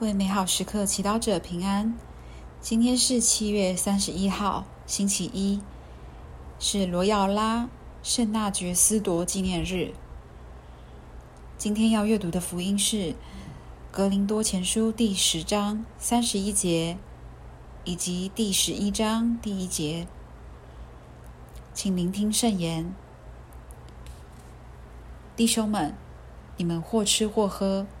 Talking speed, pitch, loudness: 165 characters per minute, 190 Hz, -25 LUFS